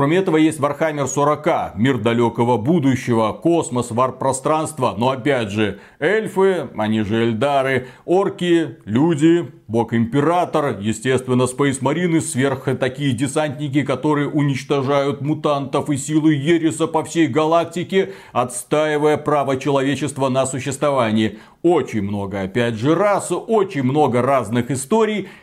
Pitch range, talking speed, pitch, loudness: 125-160 Hz, 120 wpm, 140 Hz, -19 LUFS